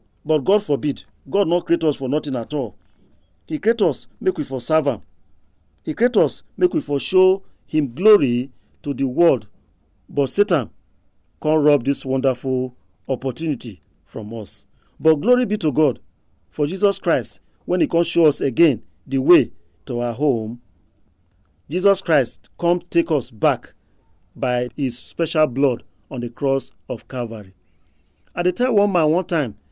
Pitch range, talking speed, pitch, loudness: 100-160 Hz, 165 wpm, 135 Hz, -20 LUFS